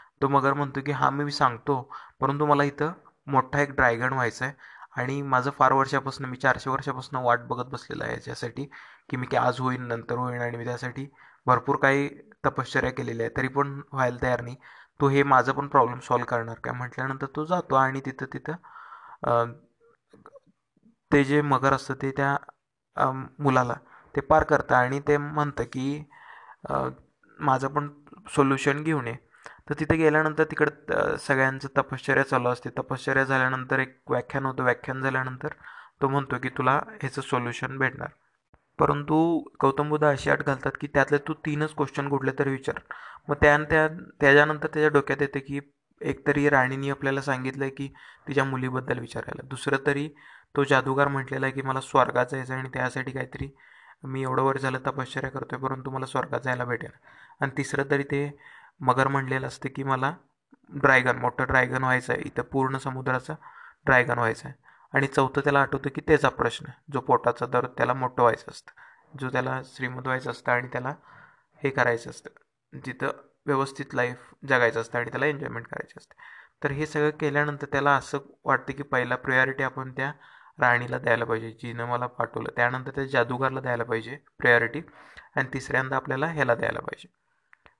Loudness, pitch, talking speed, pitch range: -26 LUFS, 135 Hz, 165 wpm, 130-145 Hz